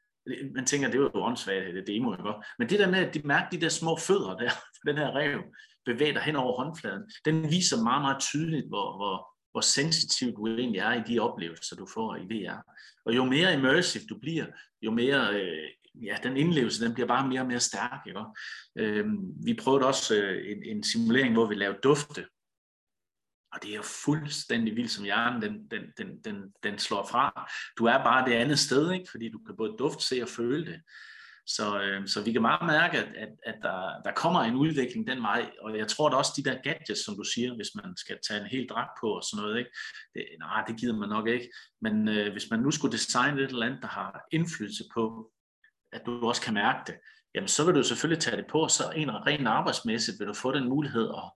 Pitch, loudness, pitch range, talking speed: 135 Hz, -29 LUFS, 115-175 Hz, 230 wpm